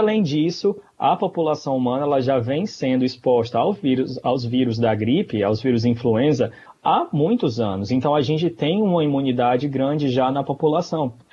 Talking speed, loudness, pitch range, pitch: 170 wpm, -21 LUFS, 125-155 Hz, 135 Hz